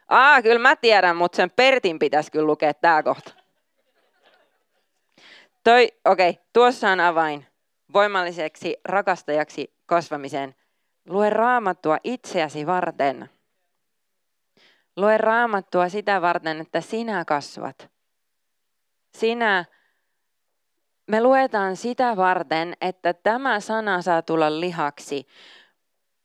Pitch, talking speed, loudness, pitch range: 180 Hz, 95 wpm, -21 LUFS, 160-220 Hz